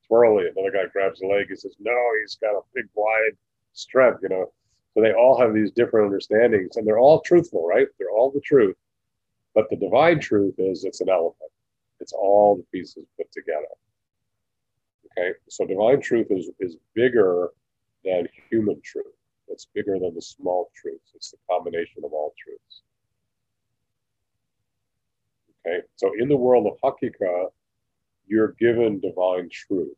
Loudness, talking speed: -22 LUFS, 160 wpm